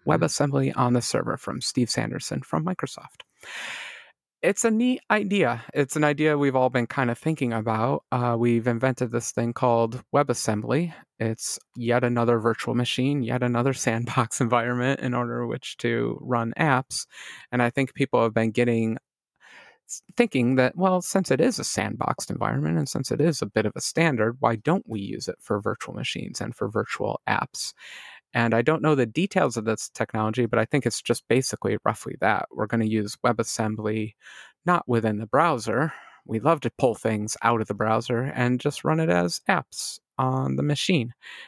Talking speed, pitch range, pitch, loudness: 180 wpm, 115-140 Hz, 120 Hz, -25 LUFS